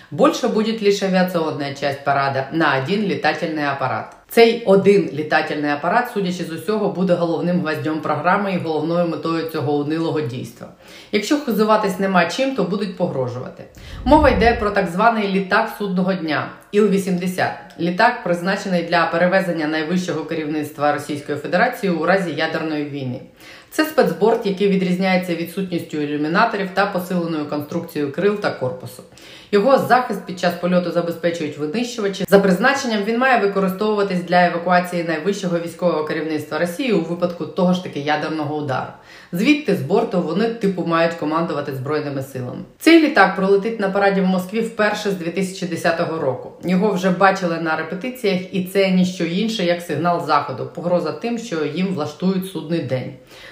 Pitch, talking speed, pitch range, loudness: 180 Hz, 150 wpm, 160-200 Hz, -19 LUFS